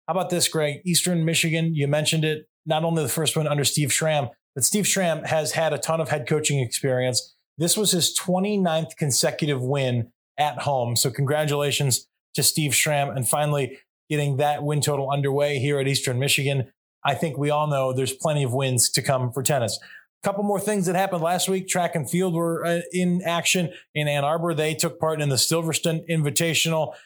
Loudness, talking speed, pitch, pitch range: -23 LUFS, 195 wpm, 150 Hz, 140-165 Hz